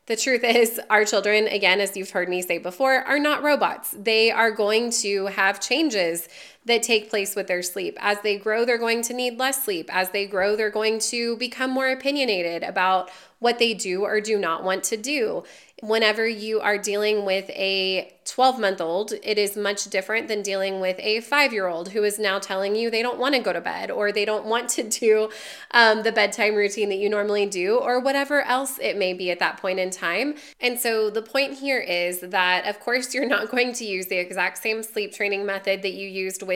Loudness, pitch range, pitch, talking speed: -22 LUFS, 195-235 Hz, 215 Hz, 225 wpm